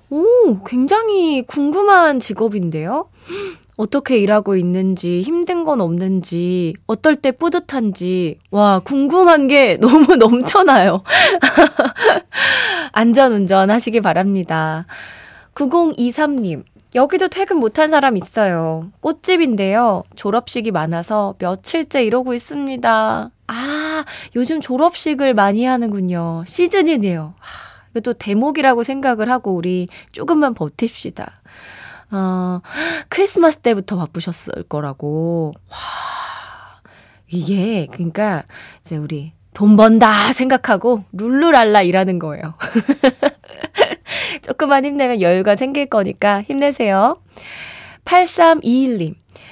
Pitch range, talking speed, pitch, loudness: 185-290 Hz, 235 characters per minute, 235 Hz, -15 LUFS